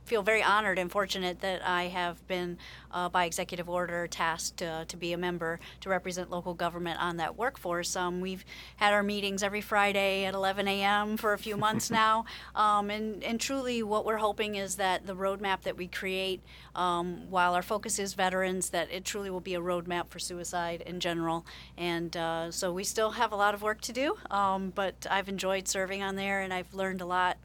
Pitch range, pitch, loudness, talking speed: 180-205 Hz, 190 Hz, -31 LUFS, 210 wpm